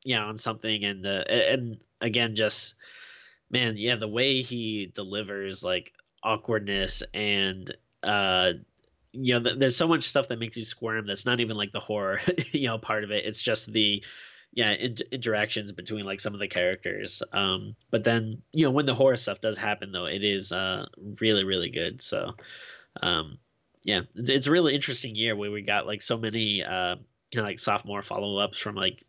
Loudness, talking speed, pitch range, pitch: -27 LUFS, 190 wpm, 100-120 Hz, 110 Hz